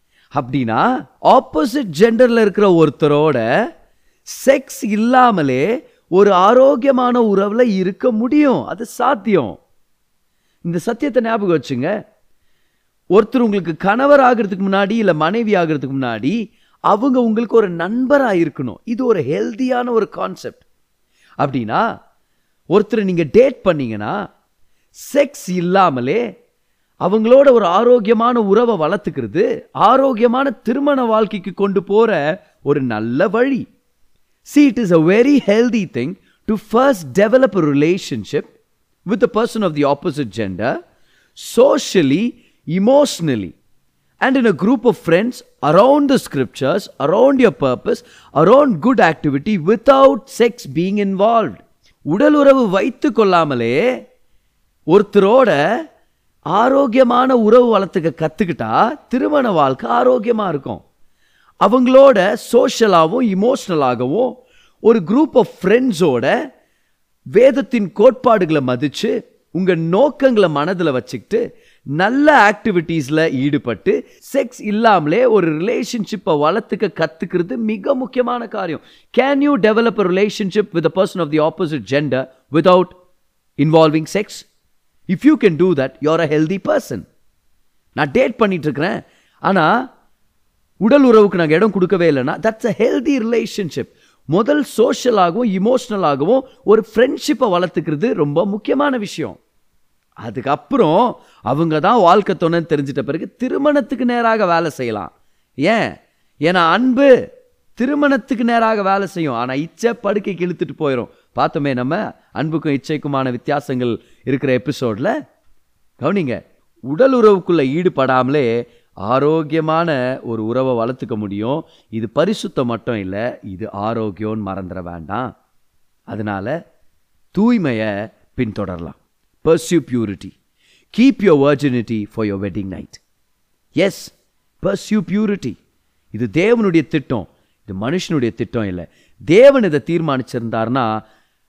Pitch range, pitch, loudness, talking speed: 145-240 Hz, 195 Hz, -15 LUFS, 105 wpm